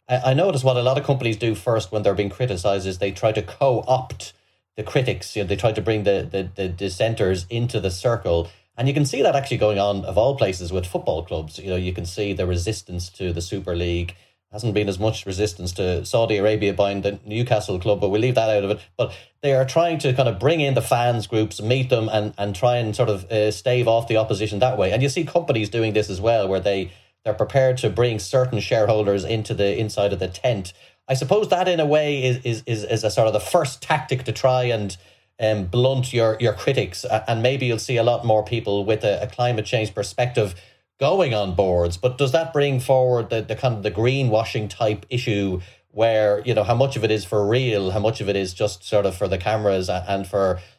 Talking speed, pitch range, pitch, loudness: 240 wpm, 100-125 Hz, 110 Hz, -21 LUFS